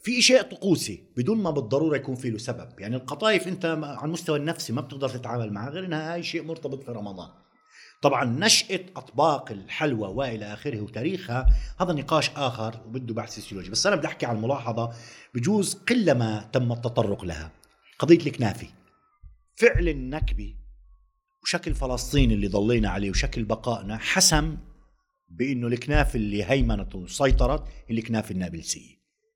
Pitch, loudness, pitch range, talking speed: 130 Hz, -26 LUFS, 110-160 Hz, 145 wpm